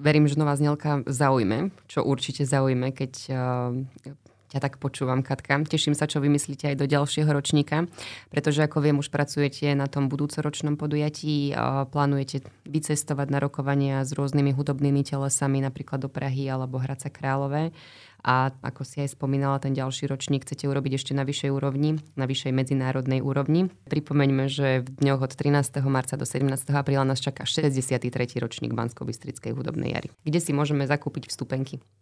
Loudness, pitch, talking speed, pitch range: -26 LUFS, 140 Hz, 155 wpm, 135-145 Hz